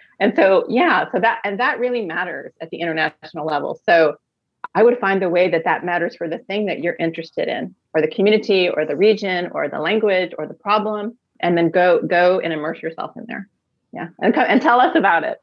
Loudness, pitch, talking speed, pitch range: -18 LUFS, 180 Hz, 220 wpm, 165-210 Hz